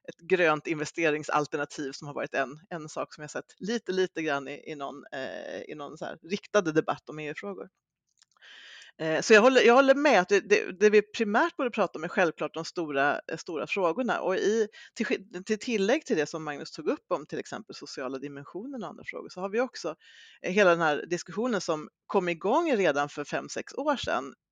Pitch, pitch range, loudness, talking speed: 175 Hz, 155-230 Hz, -28 LUFS, 205 wpm